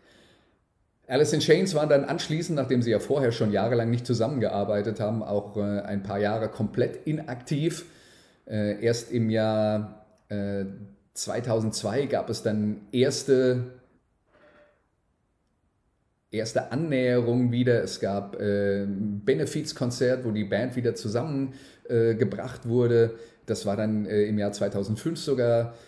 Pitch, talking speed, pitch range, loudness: 115 Hz, 115 wpm, 105-130 Hz, -26 LUFS